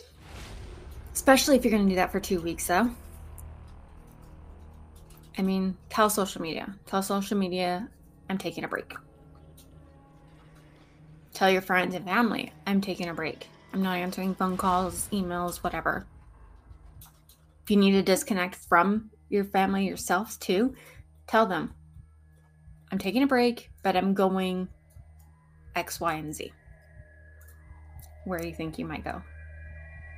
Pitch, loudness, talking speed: 175 Hz, -27 LUFS, 135 wpm